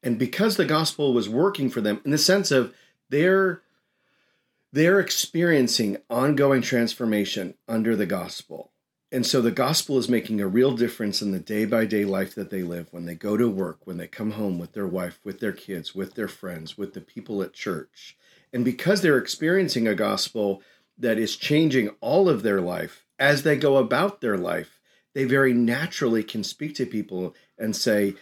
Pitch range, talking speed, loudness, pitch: 105-150 Hz, 190 wpm, -24 LUFS, 120 Hz